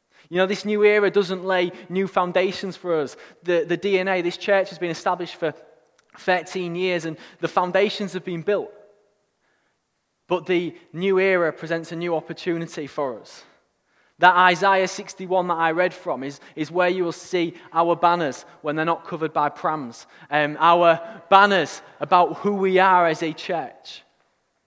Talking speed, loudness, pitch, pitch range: 170 wpm, -22 LUFS, 175 Hz, 165-190 Hz